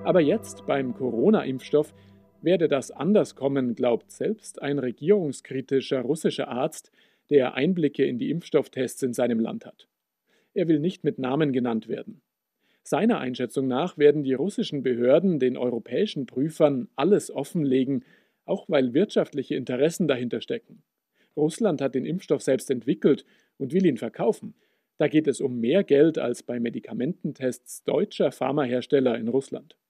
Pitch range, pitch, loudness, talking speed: 125-155 Hz, 135 Hz, -25 LUFS, 145 wpm